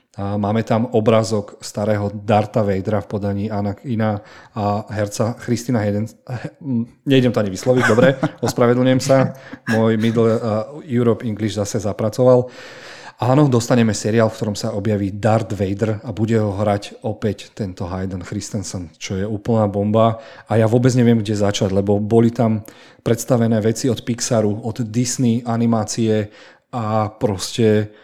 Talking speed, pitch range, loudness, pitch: 145 wpm, 105-120 Hz, -19 LUFS, 110 Hz